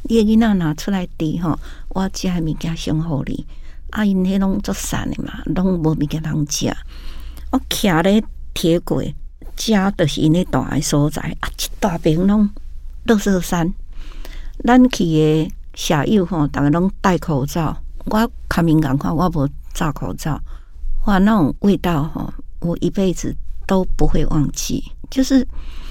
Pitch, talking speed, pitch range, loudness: 165 Hz, 210 characters per minute, 145-195 Hz, -19 LUFS